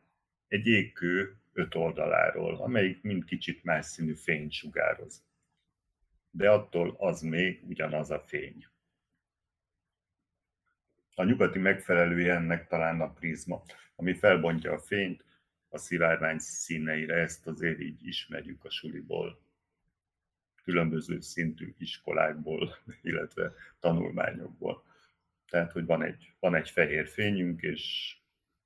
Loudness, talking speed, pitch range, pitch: -31 LUFS, 110 wpm, 80-95 Hz, 85 Hz